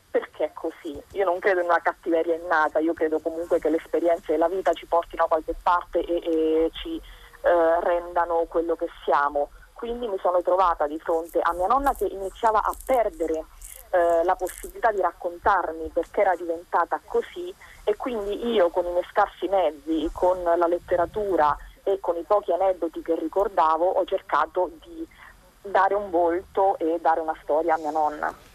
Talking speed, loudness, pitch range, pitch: 175 wpm, -24 LUFS, 165-195 Hz, 175 Hz